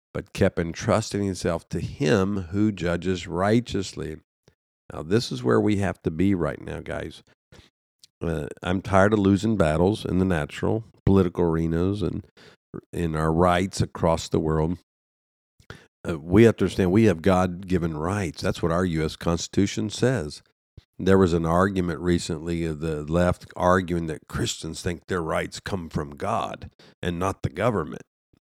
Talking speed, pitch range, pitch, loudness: 160 wpm, 85-100 Hz, 90 Hz, -24 LUFS